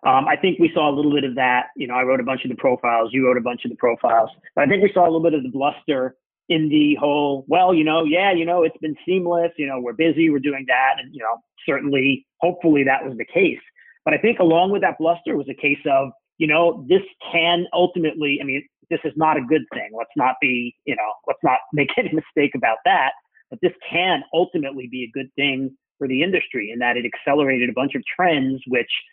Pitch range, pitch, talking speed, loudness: 135-170 Hz, 150 Hz, 250 wpm, -20 LUFS